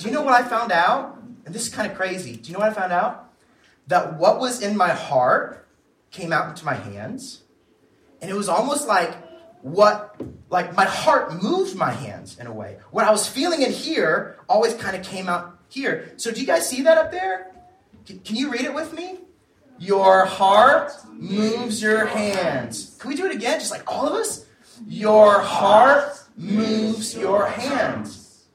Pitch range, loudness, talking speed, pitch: 195-275 Hz, -20 LUFS, 195 wpm, 220 Hz